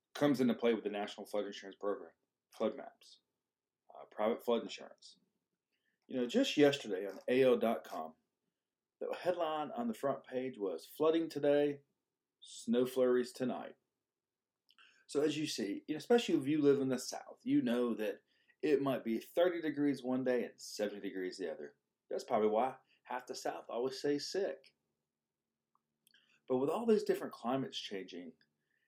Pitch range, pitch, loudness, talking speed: 110-160 Hz, 135 Hz, -36 LUFS, 155 wpm